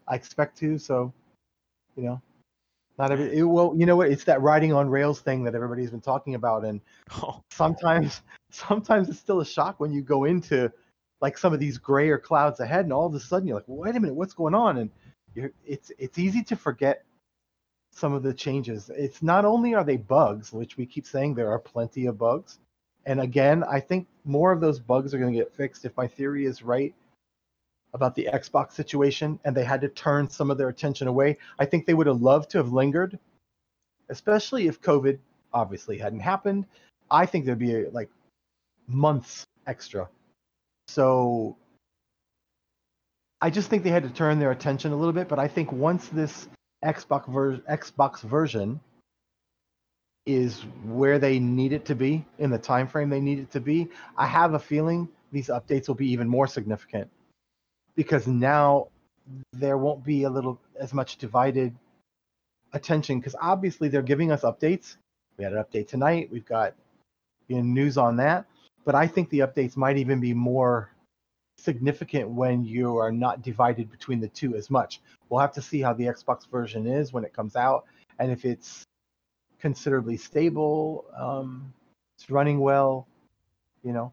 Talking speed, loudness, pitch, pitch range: 185 wpm, -25 LUFS, 140 Hz, 125-155 Hz